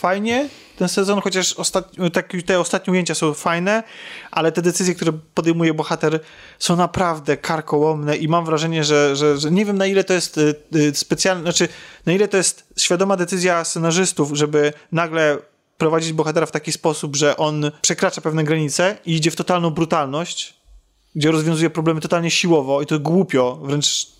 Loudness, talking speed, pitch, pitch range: -19 LUFS, 165 wpm, 165 Hz, 155-180 Hz